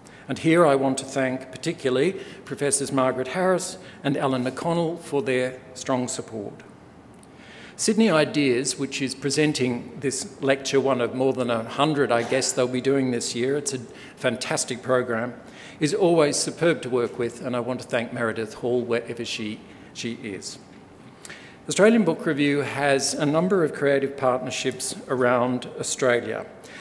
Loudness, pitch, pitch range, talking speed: -24 LUFS, 130 Hz, 125-145 Hz, 150 wpm